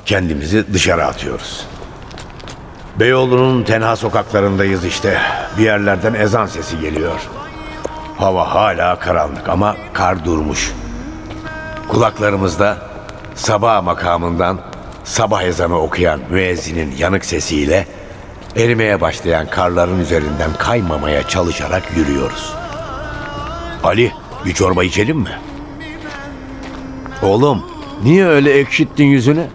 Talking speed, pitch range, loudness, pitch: 90 wpm, 90-110 Hz, -15 LUFS, 100 Hz